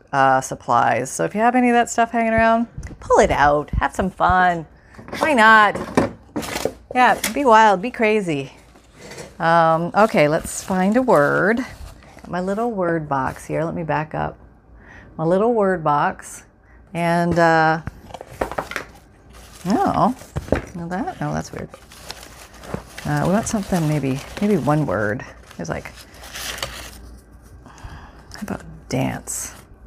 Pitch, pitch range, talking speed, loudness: 175 Hz, 145-220 Hz, 135 wpm, -19 LUFS